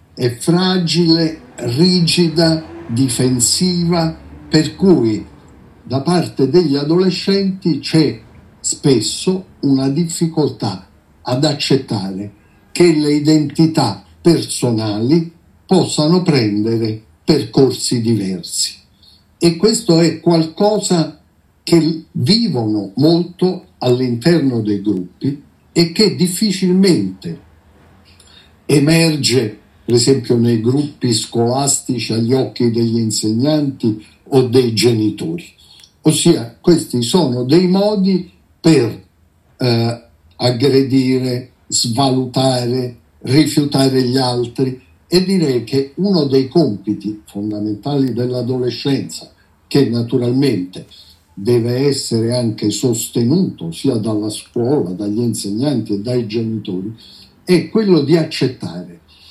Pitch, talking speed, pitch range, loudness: 130 Hz, 90 wpm, 115-160 Hz, -15 LUFS